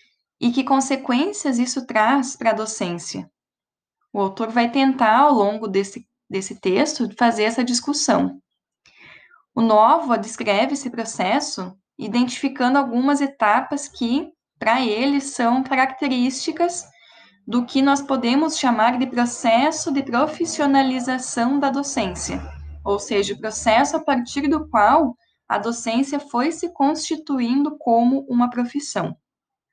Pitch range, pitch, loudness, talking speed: 225-280 Hz, 245 Hz, -20 LUFS, 120 wpm